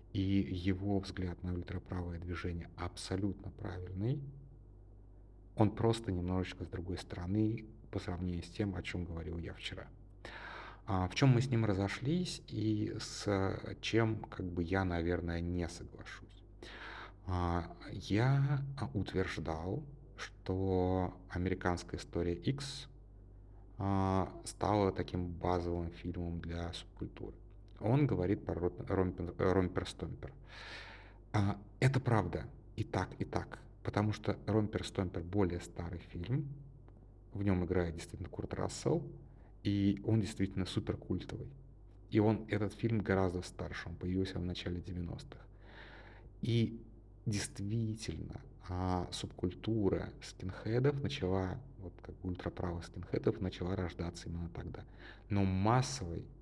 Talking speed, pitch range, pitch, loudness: 115 wpm, 90-110 Hz, 95 Hz, -37 LUFS